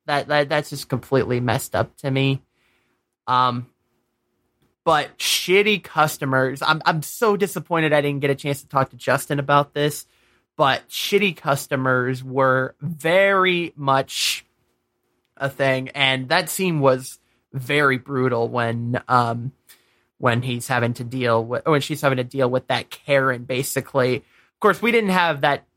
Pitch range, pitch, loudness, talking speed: 125-150 Hz, 135 Hz, -21 LUFS, 150 wpm